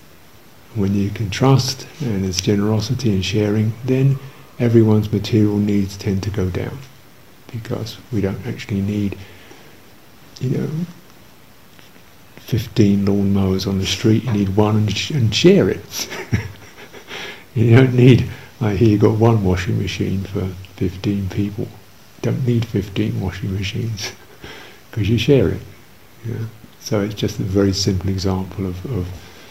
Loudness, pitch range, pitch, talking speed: -18 LUFS, 100-120 Hz, 105 Hz, 150 wpm